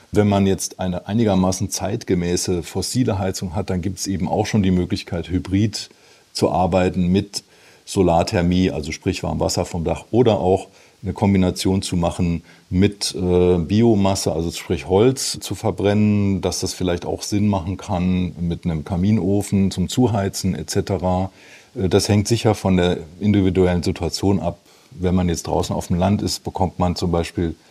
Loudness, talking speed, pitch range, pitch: -20 LUFS, 160 wpm, 90-100 Hz, 95 Hz